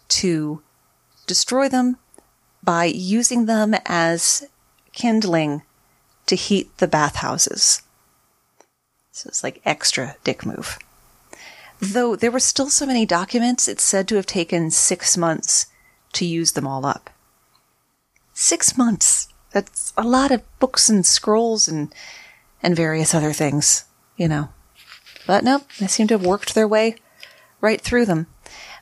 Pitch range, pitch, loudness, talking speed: 165-235 Hz, 195 Hz, -18 LUFS, 135 wpm